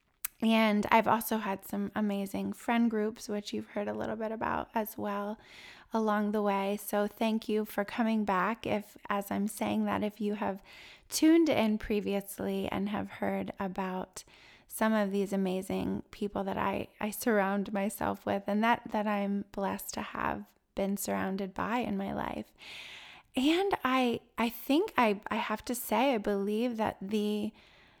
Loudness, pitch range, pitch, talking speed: -32 LUFS, 195-225 Hz, 210 Hz, 165 wpm